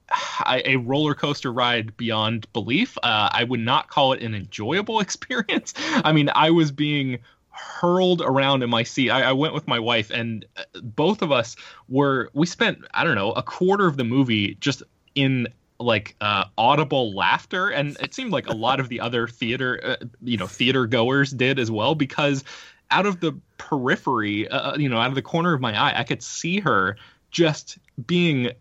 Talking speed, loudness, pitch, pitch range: 195 wpm, -22 LUFS, 130 Hz, 120-150 Hz